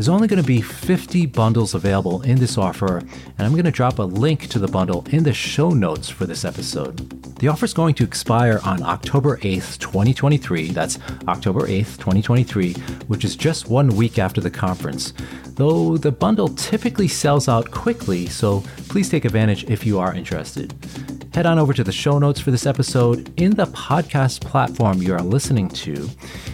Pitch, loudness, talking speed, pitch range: 120 Hz, -19 LUFS, 190 wpm, 95-150 Hz